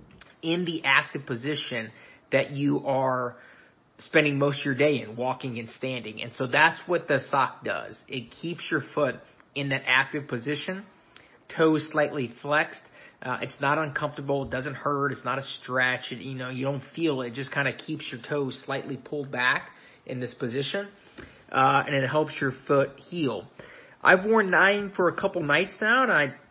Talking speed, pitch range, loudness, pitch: 185 wpm, 130-155 Hz, -26 LUFS, 140 Hz